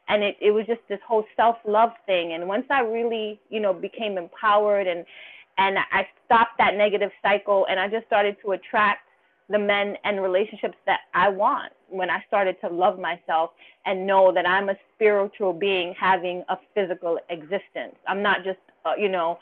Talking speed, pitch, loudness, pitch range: 190 wpm, 200 Hz, -23 LUFS, 185-210 Hz